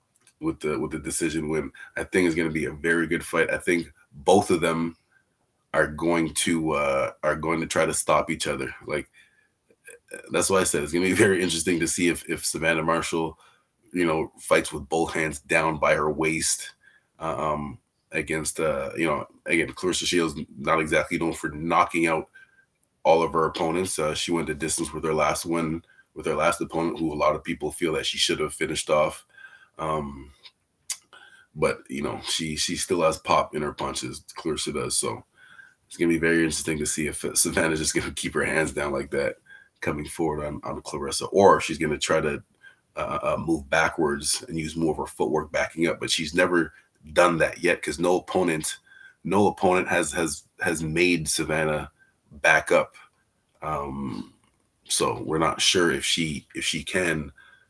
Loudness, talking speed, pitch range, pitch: -25 LUFS, 195 wpm, 80-90 Hz, 80 Hz